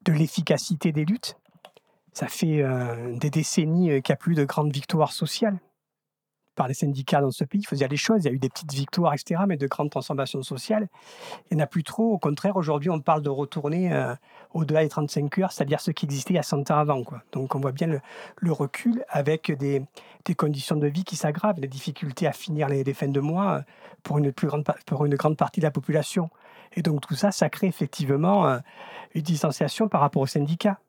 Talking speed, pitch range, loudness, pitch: 230 wpm, 145-180 Hz, -26 LUFS, 155 Hz